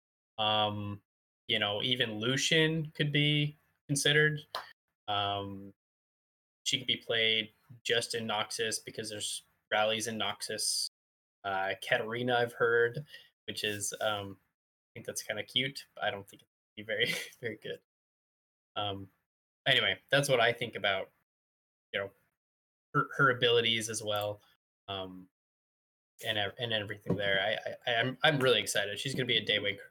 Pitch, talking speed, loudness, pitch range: 105 Hz, 150 wpm, -31 LUFS, 95-120 Hz